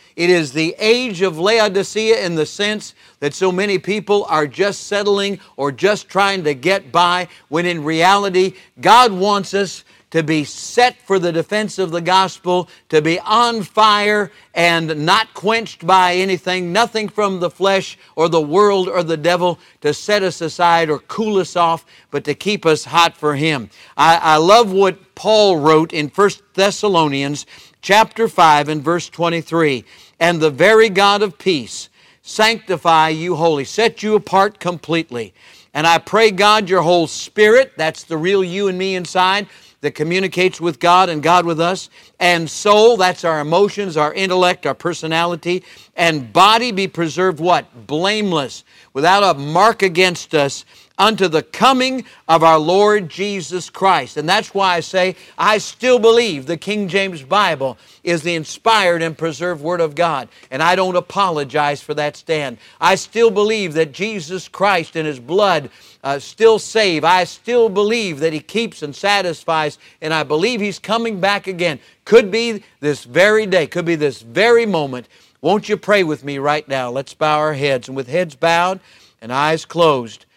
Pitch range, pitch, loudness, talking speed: 160-200 Hz, 180 Hz, -16 LUFS, 170 wpm